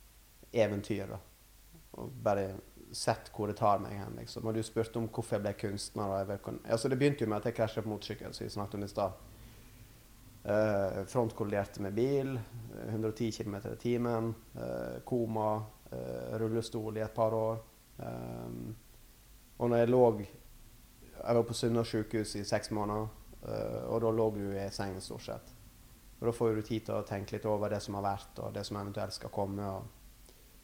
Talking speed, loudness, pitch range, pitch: 175 wpm, -35 LUFS, 100-115 Hz, 110 Hz